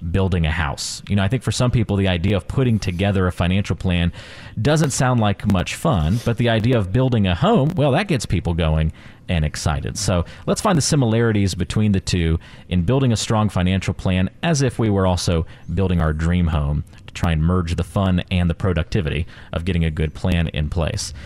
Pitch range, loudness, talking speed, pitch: 85-115 Hz, -20 LUFS, 215 wpm, 95 Hz